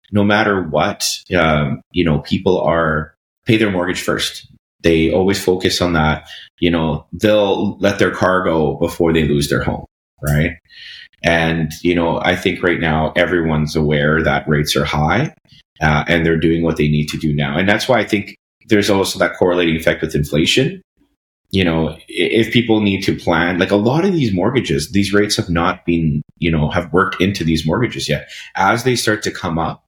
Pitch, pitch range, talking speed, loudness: 85 Hz, 80-100 Hz, 195 wpm, -16 LUFS